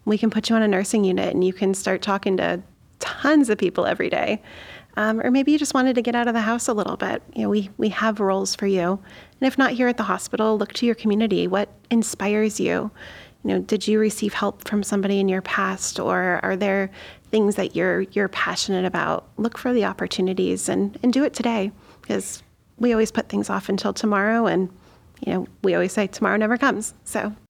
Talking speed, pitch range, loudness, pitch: 225 wpm, 195-225 Hz, -22 LUFS, 210 Hz